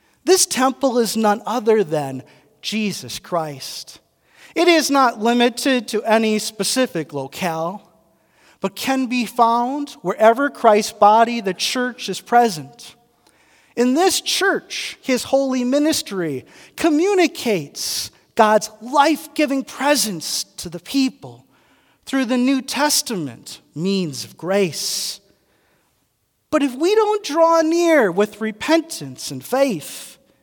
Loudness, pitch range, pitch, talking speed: -19 LUFS, 190-280 Hz, 230 Hz, 115 wpm